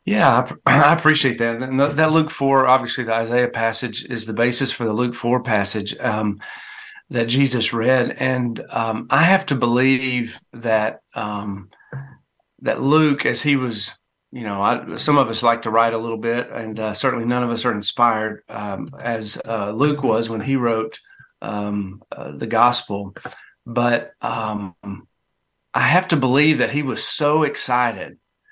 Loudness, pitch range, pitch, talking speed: -19 LUFS, 110-135 Hz, 120 Hz, 170 wpm